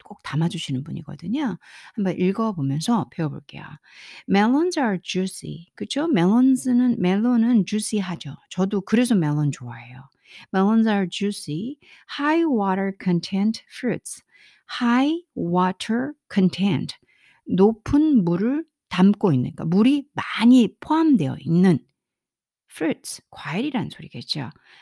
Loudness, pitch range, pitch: -22 LUFS, 175-250 Hz, 200 Hz